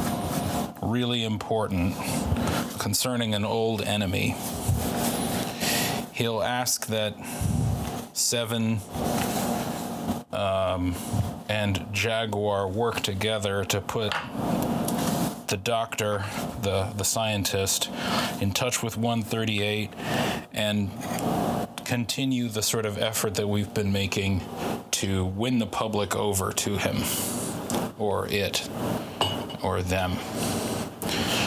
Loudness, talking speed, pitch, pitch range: -27 LUFS, 90 wpm, 105 Hz, 100-115 Hz